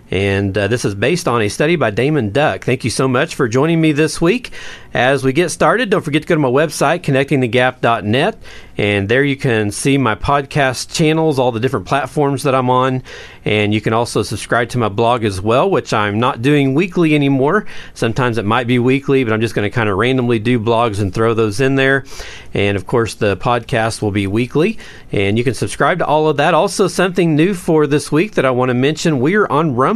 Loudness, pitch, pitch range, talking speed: -15 LUFS, 130 Hz, 115-150 Hz, 230 wpm